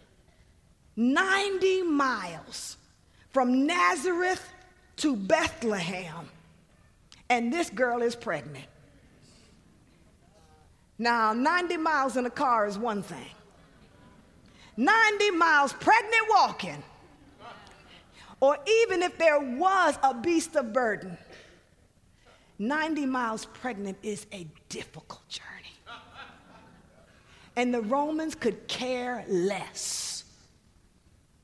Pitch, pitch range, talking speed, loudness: 255 Hz, 200-325 Hz, 90 wpm, -27 LUFS